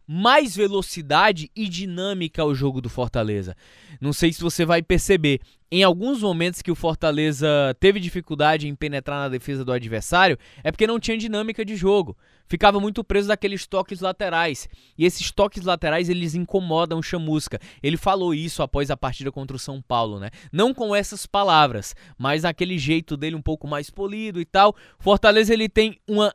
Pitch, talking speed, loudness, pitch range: 170 Hz, 180 wpm, -22 LUFS, 145-195 Hz